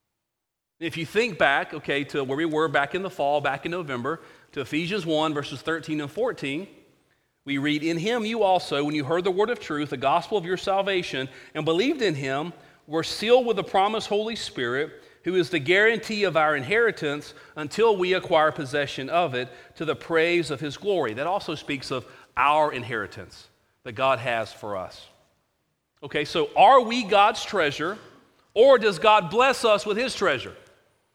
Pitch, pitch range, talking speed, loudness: 165 Hz, 145-205 Hz, 185 wpm, -24 LUFS